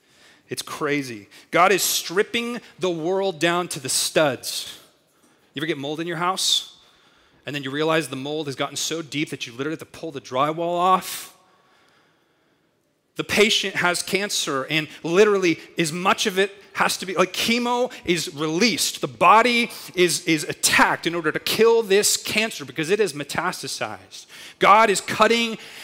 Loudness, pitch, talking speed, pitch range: -21 LUFS, 170 Hz, 165 wpm, 150-200 Hz